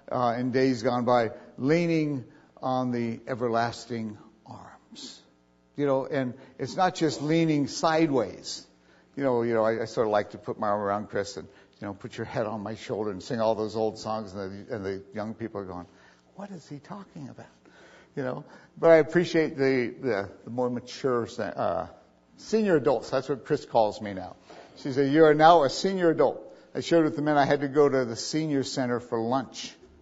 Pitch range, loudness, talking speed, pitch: 110-145 Hz, -26 LUFS, 205 wpm, 125 Hz